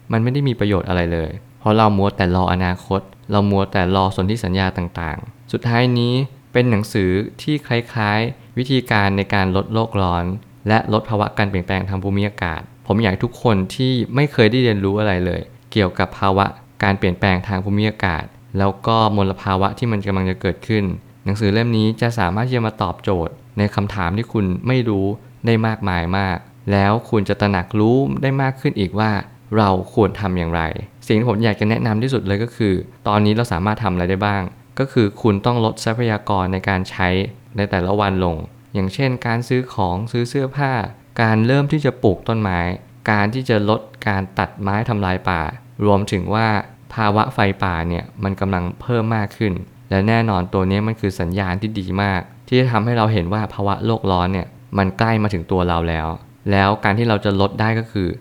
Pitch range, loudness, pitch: 95-115 Hz, -19 LUFS, 105 Hz